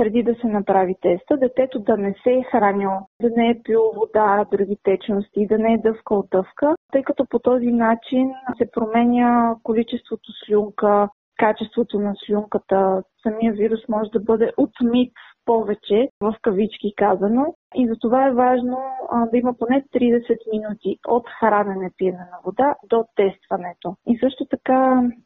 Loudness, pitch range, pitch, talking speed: -20 LUFS, 205-245 Hz, 225 Hz, 155 wpm